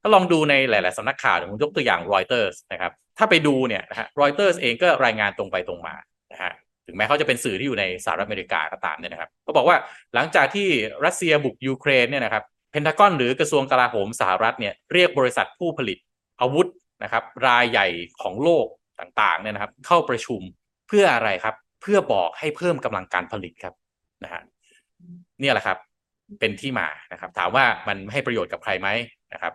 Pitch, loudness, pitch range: 140 Hz, -21 LUFS, 110-180 Hz